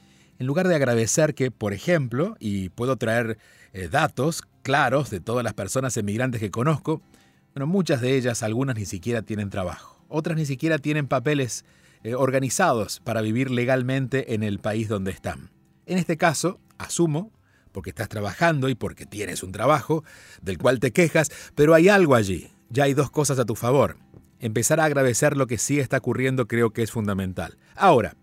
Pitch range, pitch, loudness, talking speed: 105-150 Hz, 130 Hz, -23 LUFS, 180 wpm